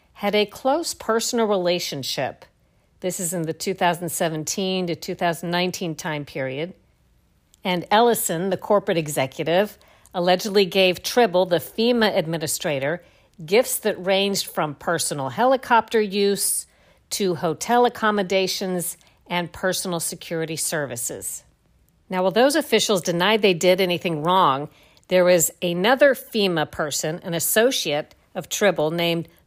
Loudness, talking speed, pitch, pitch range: -22 LUFS, 120 wpm, 180 Hz, 165-205 Hz